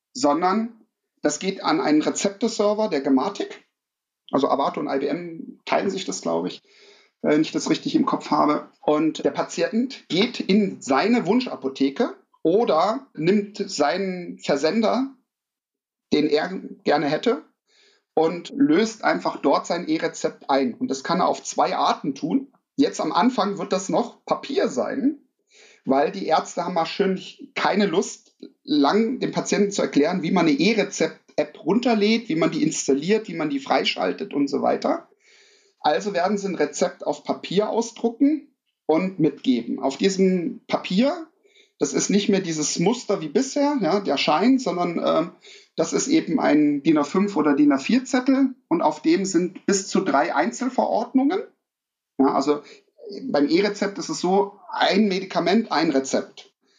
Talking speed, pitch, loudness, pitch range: 155 wpm, 215 Hz, -22 LUFS, 175-280 Hz